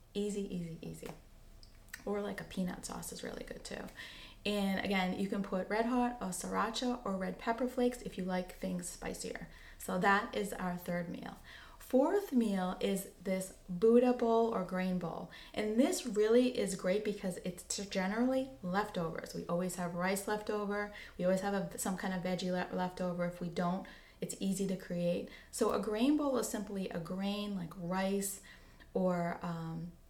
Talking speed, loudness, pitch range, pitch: 175 wpm, -36 LUFS, 180-215 Hz, 195 Hz